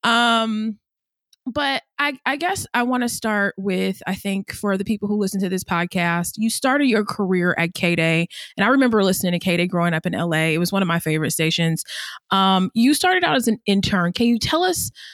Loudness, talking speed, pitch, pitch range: -20 LUFS, 215 wpm, 200 Hz, 175-235 Hz